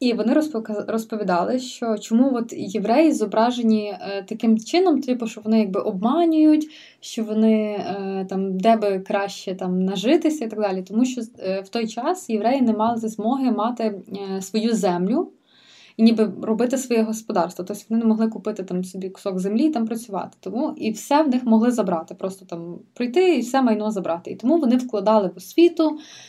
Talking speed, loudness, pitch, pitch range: 170 wpm, -21 LUFS, 220 Hz, 200-250 Hz